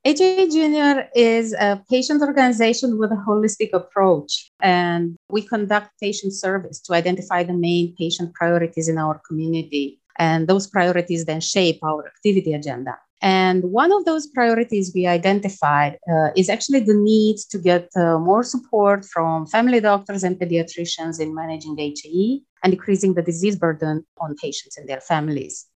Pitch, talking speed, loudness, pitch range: 185 Hz, 160 wpm, -20 LUFS, 165-215 Hz